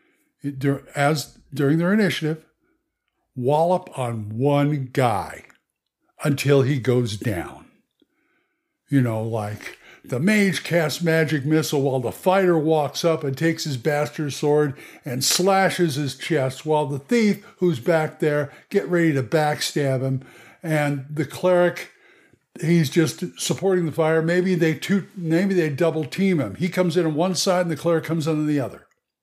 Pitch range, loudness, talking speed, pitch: 140-175 Hz, -22 LUFS, 155 wpm, 155 Hz